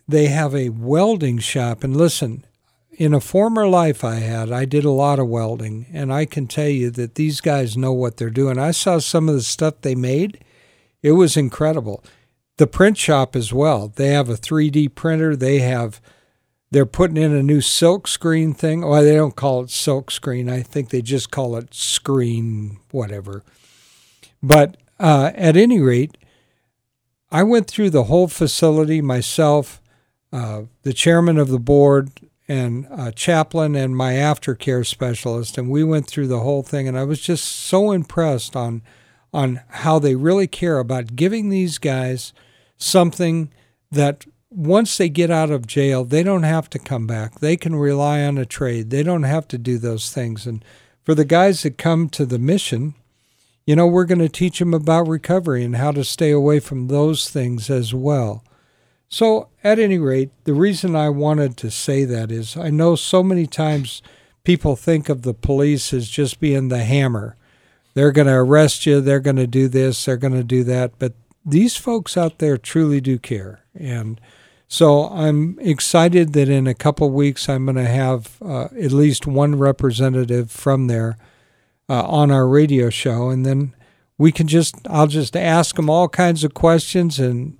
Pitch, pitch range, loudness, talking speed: 140 Hz, 125-155 Hz, -17 LUFS, 185 wpm